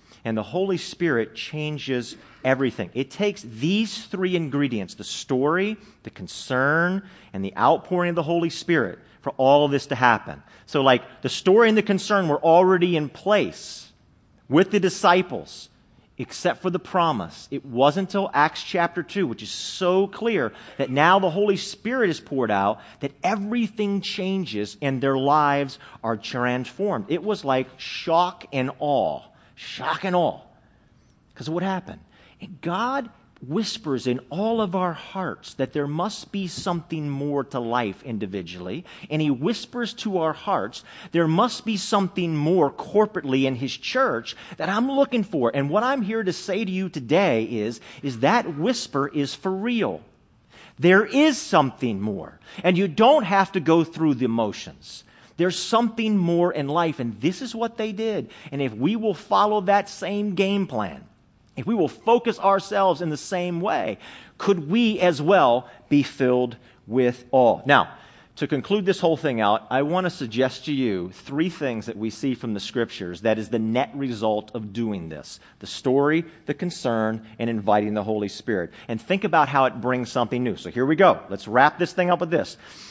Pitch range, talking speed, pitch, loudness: 125-195 Hz, 175 wpm, 160 Hz, -23 LUFS